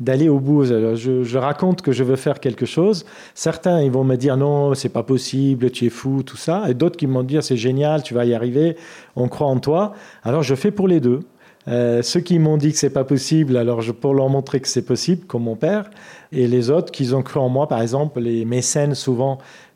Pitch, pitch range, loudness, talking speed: 135 Hz, 125-155 Hz, -19 LUFS, 245 wpm